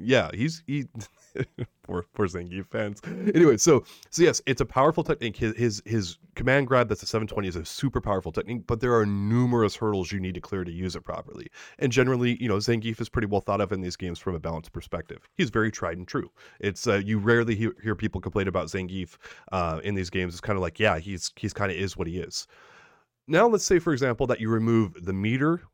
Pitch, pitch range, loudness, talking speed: 105 Hz, 95-120 Hz, -26 LUFS, 230 wpm